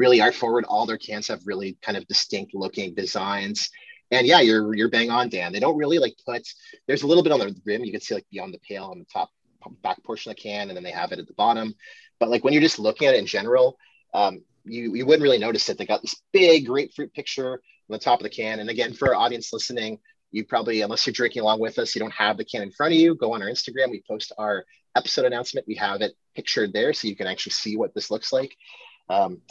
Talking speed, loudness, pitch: 265 wpm, -23 LUFS, 150 Hz